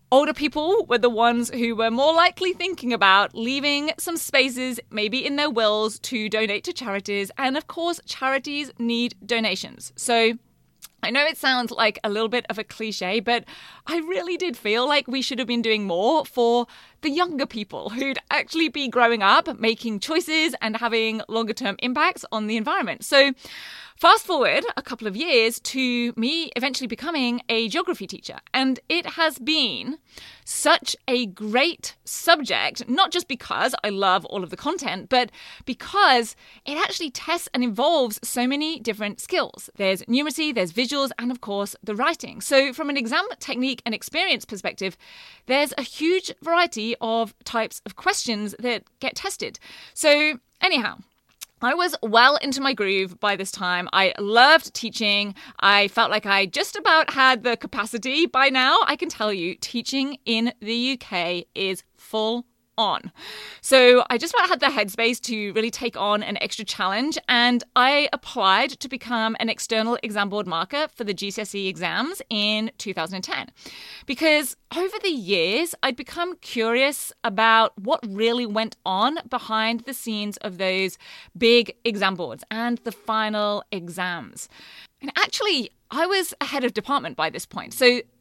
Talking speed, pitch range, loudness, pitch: 165 wpm, 220-290 Hz, -22 LUFS, 240 Hz